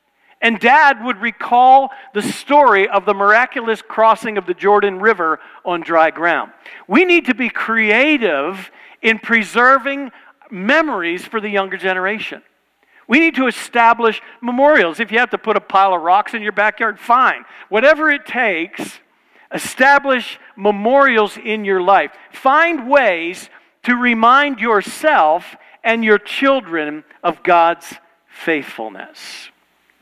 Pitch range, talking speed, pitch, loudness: 200-265 Hz, 130 wpm, 225 Hz, -14 LUFS